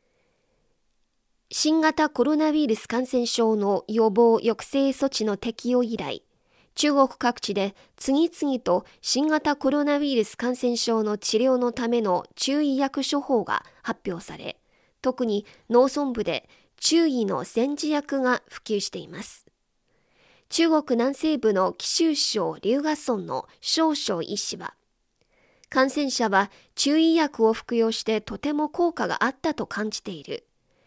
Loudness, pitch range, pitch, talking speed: -24 LUFS, 225-295 Hz, 250 Hz, 245 characters per minute